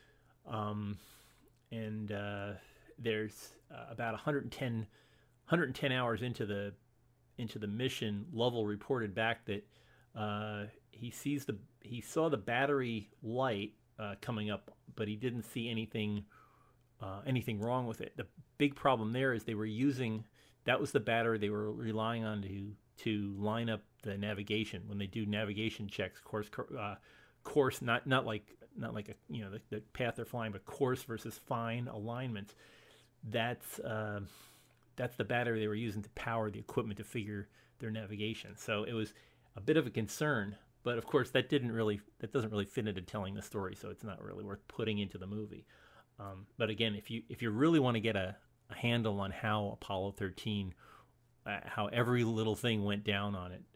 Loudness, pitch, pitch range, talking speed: -38 LUFS, 110 Hz, 105-120 Hz, 180 wpm